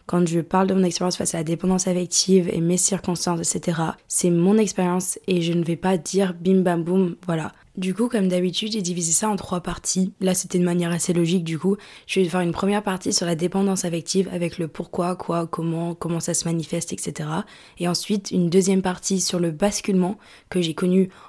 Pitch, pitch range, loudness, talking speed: 180 Hz, 170-190 Hz, -22 LUFS, 215 wpm